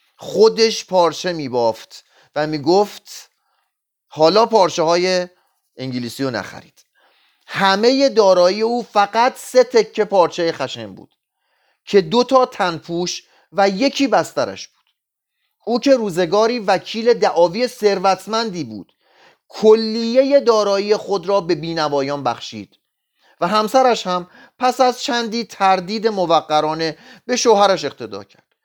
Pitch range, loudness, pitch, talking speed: 170-235 Hz, -17 LUFS, 200 Hz, 115 wpm